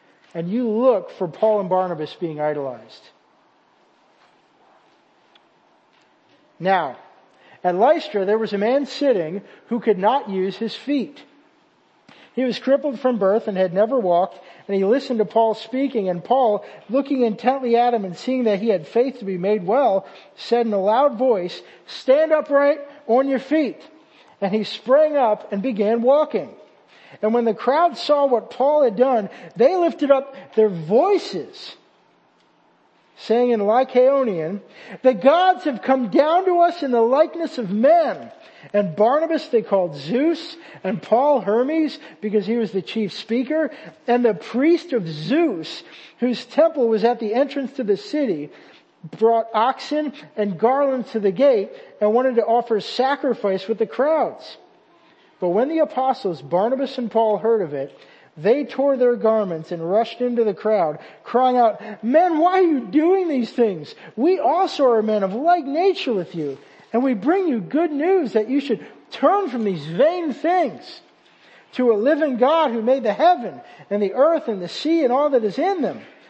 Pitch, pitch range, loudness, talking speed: 240 Hz, 210-285 Hz, -20 LUFS, 170 wpm